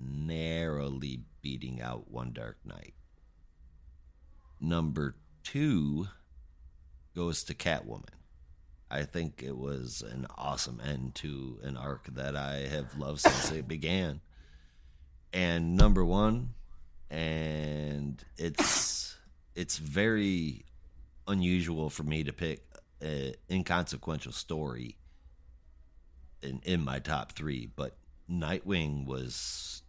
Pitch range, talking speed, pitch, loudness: 65-80 Hz, 100 wpm, 70 Hz, -34 LUFS